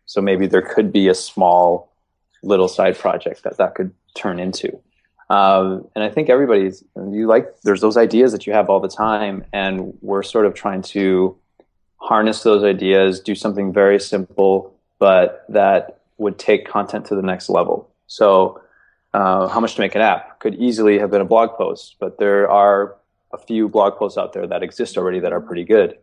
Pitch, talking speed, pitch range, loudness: 100 Hz, 195 wpm, 95-105 Hz, -17 LUFS